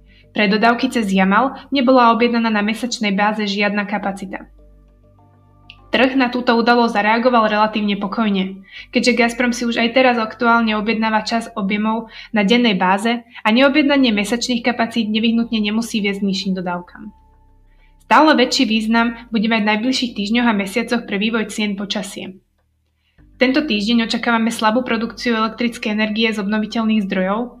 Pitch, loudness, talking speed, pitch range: 225 Hz, -17 LUFS, 140 wpm, 205-235 Hz